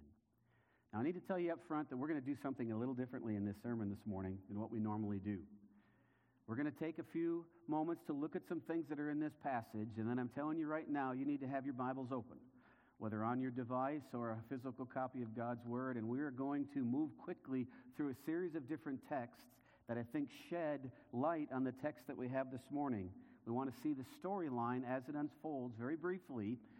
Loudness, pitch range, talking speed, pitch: -44 LUFS, 120-150 Hz, 235 wpm, 130 Hz